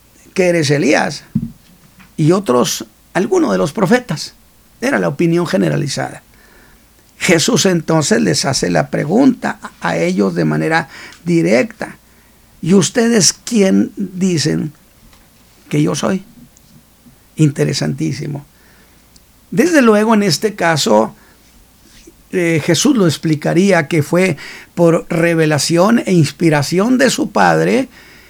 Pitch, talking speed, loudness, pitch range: 175 Hz, 105 wpm, -14 LUFS, 160-210 Hz